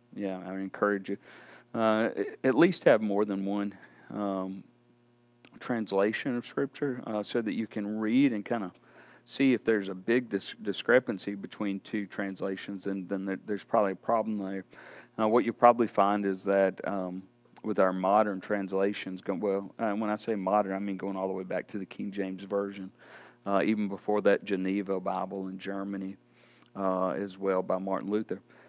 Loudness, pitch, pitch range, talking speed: -30 LUFS, 100 Hz, 95-110 Hz, 180 wpm